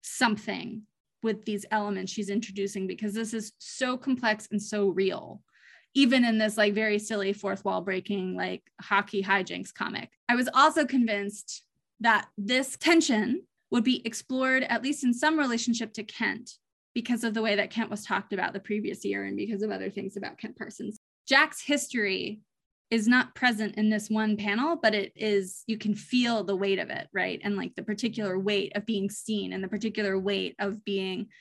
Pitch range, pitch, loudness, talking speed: 200-235 Hz, 215 Hz, -28 LUFS, 185 wpm